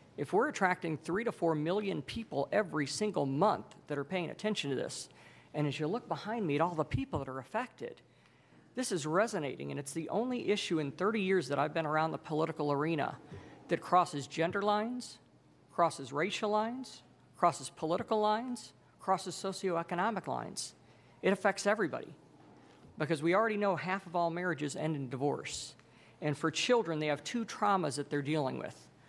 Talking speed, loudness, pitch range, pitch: 175 wpm, -34 LUFS, 145-200 Hz, 165 Hz